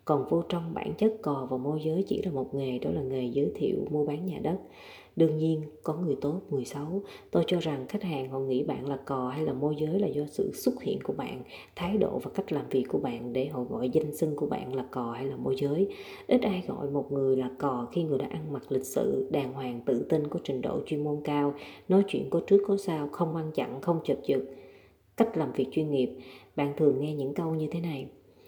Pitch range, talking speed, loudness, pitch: 135-165 Hz, 255 wpm, -30 LUFS, 145 Hz